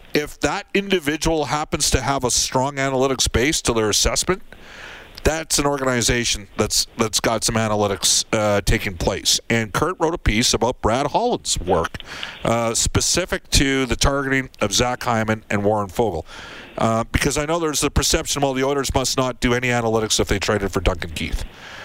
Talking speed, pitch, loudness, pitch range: 180 wpm, 125 Hz, -20 LUFS, 110-140 Hz